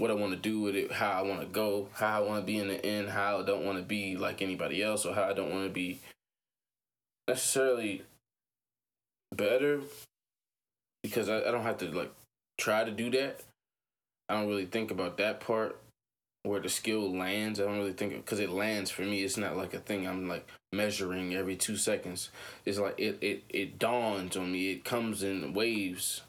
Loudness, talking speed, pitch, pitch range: -33 LUFS, 210 wpm, 100 Hz, 95-110 Hz